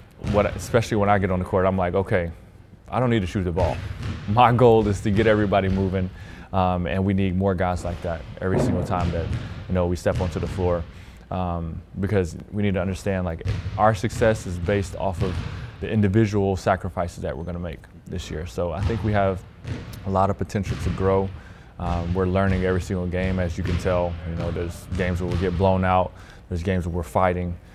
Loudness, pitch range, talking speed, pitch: -24 LUFS, 90-100 Hz, 220 wpm, 95 Hz